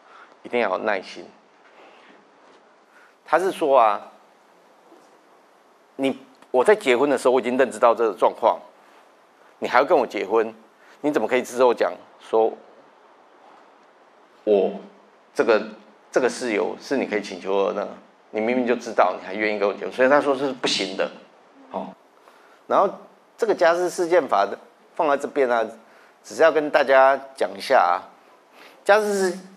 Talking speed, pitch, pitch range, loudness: 220 characters per minute, 135 Hz, 110-175 Hz, -21 LUFS